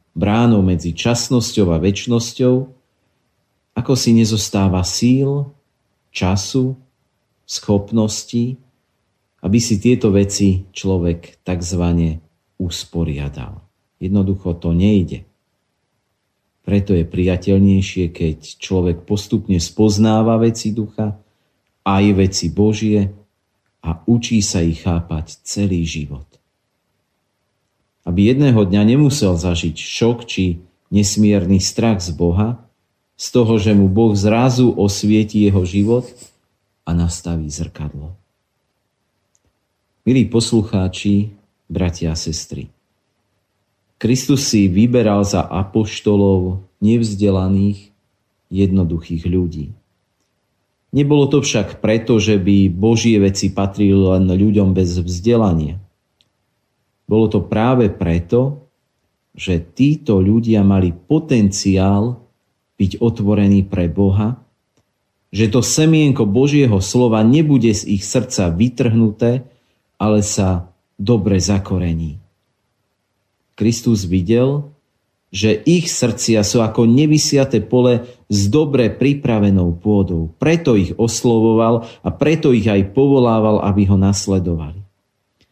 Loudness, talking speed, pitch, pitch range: -16 LUFS, 100 wpm, 100 Hz, 95-115 Hz